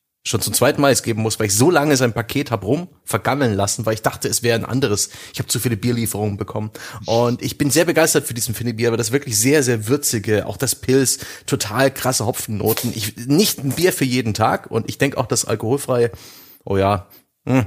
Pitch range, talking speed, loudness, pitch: 110-135 Hz, 225 wpm, -19 LUFS, 120 Hz